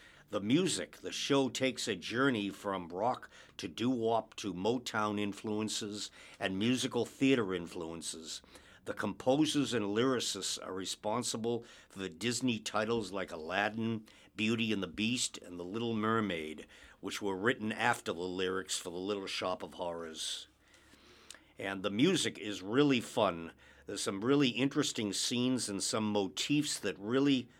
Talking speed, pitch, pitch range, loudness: 145 wpm, 110 Hz, 95-125 Hz, -34 LUFS